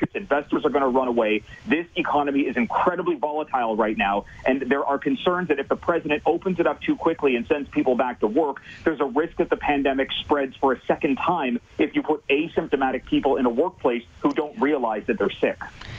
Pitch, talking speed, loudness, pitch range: 145 Hz, 220 wpm, -23 LUFS, 130-160 Hz